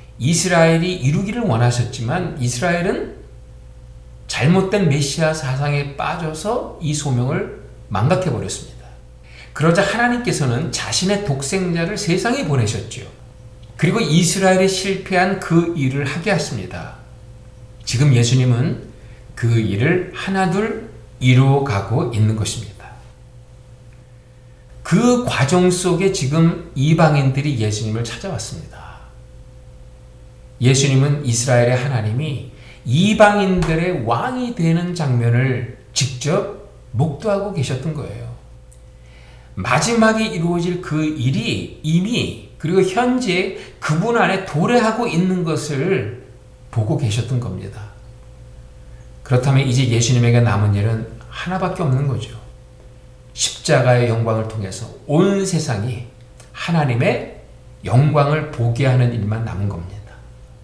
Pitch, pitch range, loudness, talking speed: 130 Hz, 120-170 Hz, -18 LUFS, 260 characters per minute